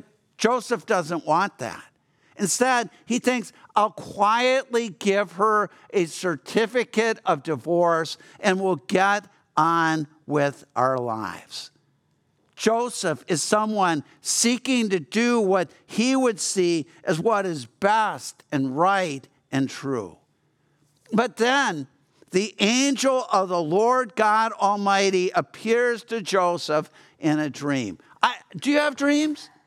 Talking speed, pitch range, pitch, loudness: 120 wpm, 165-230 Hz, 195 Hz, -23 LUFS